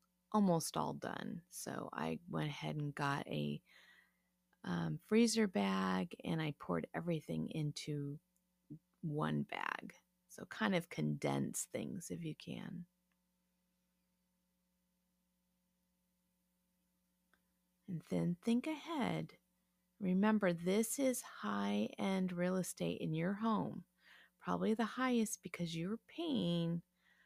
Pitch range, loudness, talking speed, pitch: 160-190 Hz, -39 LUFS, 105 wpm, 180 Hz